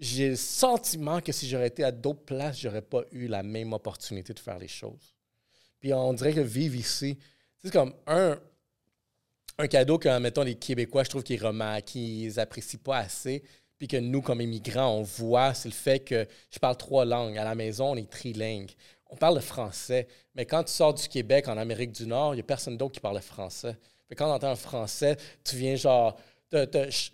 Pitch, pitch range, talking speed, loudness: 125 Hz, 115-140 Hz, 220 wpm, -29 LUFS